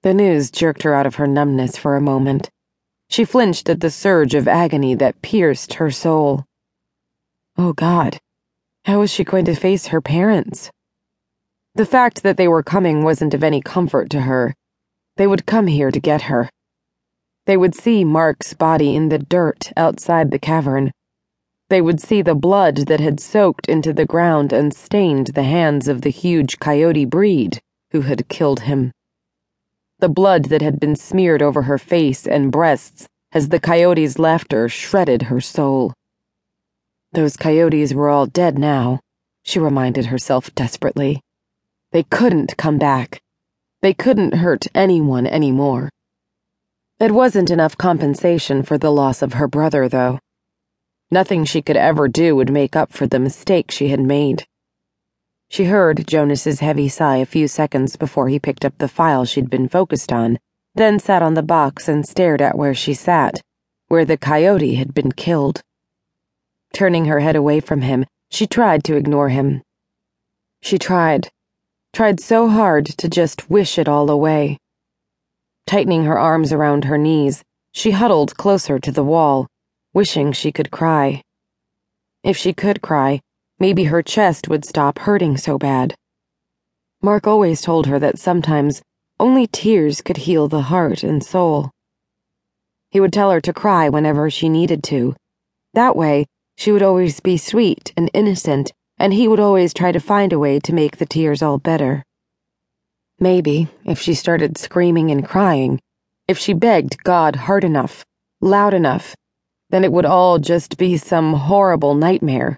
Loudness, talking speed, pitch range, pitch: -16 LUFS, 165 wpm, 140-180 Hz, 155 Hz